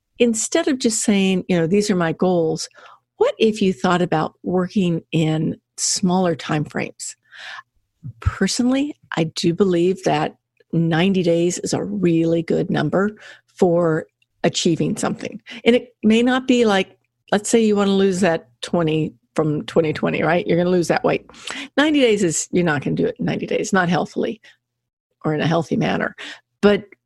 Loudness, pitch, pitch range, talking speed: -19 LUFS, 180 Hz, 165-210 Hz, 170 wpm